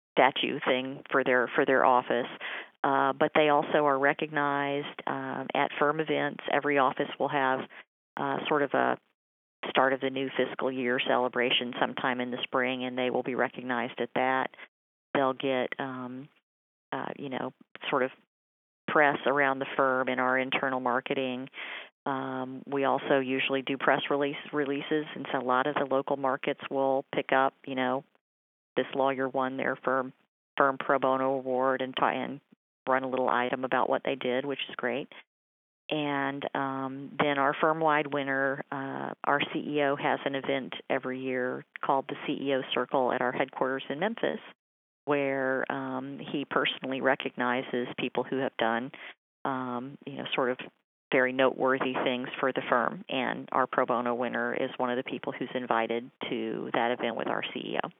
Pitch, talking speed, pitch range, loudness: 130 Hz, 170 wpm, 125-140 Hz, -29 LUFS